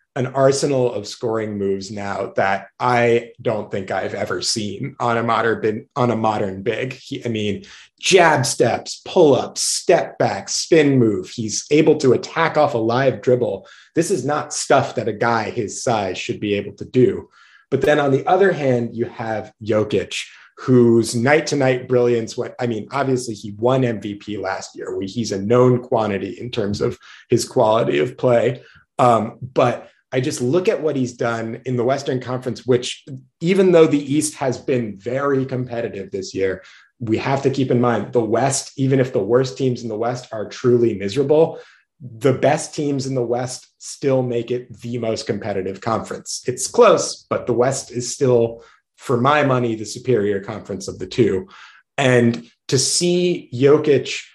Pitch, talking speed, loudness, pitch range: 125 Hz, 180 wpm, -19 LUFS, 115-135 Hz